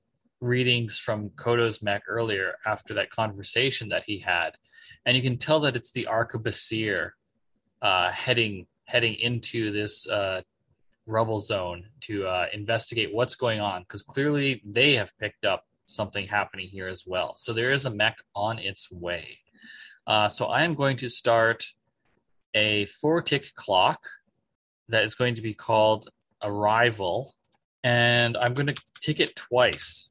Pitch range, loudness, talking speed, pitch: 105-125 Hz, -26 LUFS, 155 wpm, 115 Hz